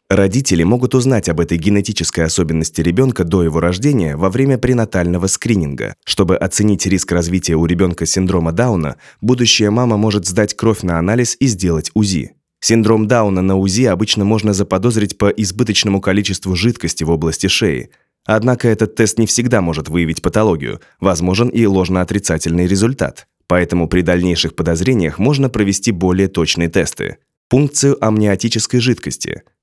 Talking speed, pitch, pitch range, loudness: 145 wpm, 100 Hz, 90-115 Hz, -15 LUFS